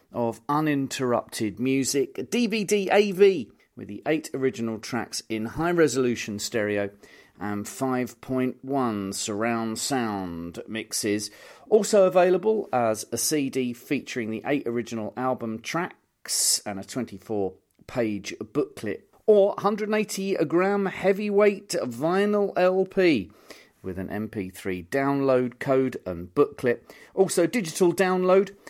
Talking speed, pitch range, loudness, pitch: 105 wpm, 110-185 Hz, -25 LUFS, 130 Hz